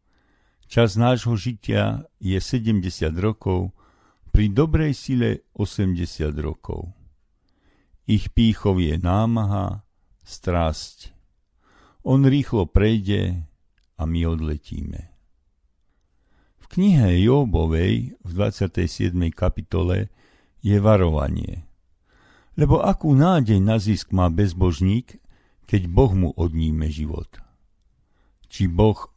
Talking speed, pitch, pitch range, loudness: 90 wpm, 95 Hz, 85-110 Hz, -21 LUFS